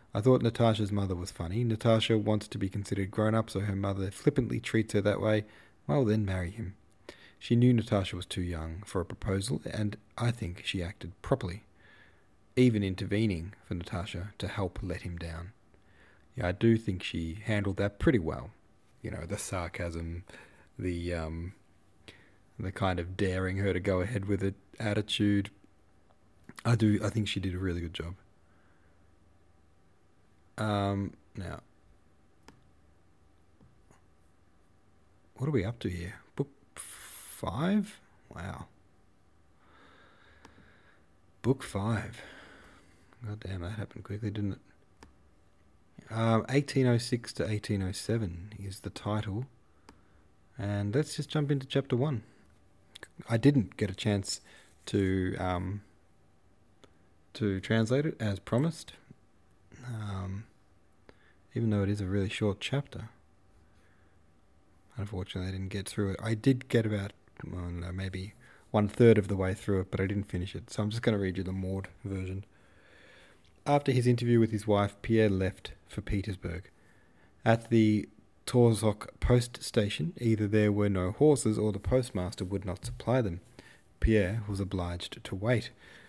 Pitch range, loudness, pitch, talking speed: 90-110 Hz, -31 LUFS, 100 Hz, 145 wpm